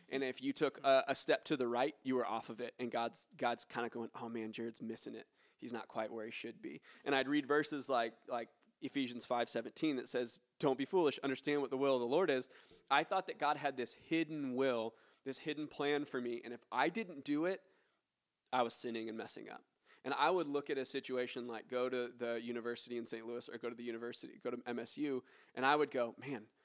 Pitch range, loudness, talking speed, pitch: 120-145 Hz, -39 LUFS, 245 wpm, 125 Hz